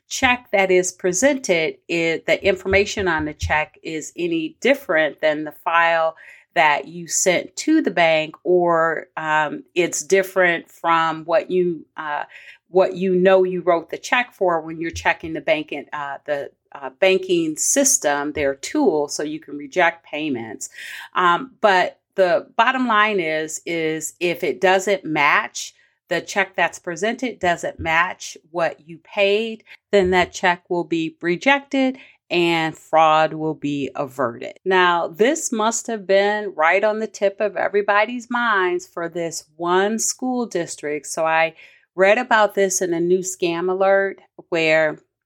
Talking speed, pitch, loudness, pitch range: 150 wpm, 180 Hz, -20 LUFS, 165-215 Hz